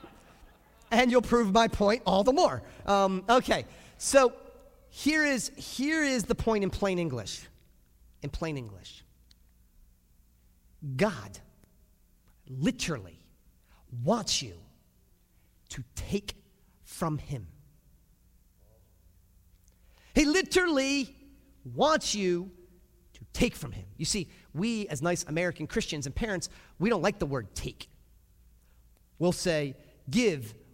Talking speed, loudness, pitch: 110 wpm, -29 LUFS, 170 Hz